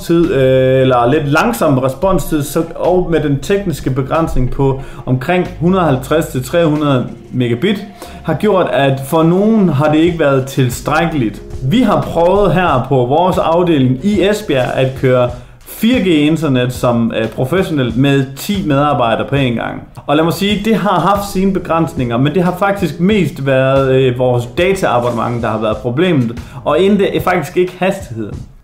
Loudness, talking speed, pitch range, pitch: -13 LUFS, 155 wpm, 130-180 Hz, 150 Hz